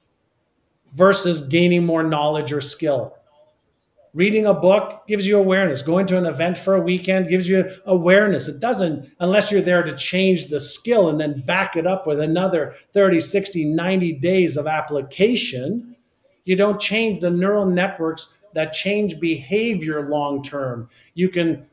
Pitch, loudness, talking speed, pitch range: 180 Hz, -19 LUFS, 155 wpm, 155-195 Hz